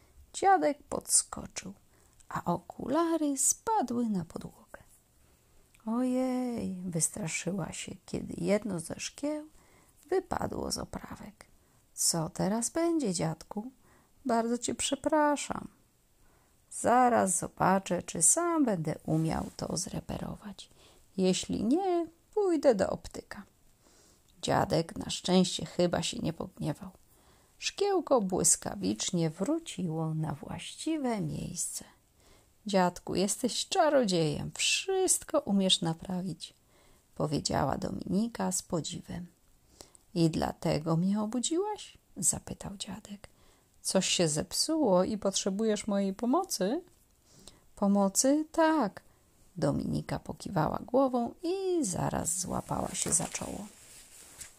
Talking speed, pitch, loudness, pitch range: 90 wpm, 215 Hz, -30 LUFS, 180-295 Hz